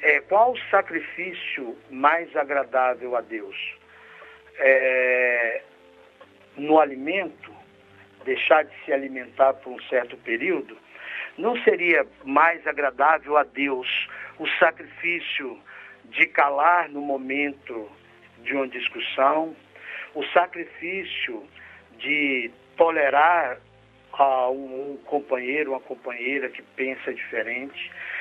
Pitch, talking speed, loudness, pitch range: 140 Hz, 100 wpm, -23 LUFS, 130-175 Hz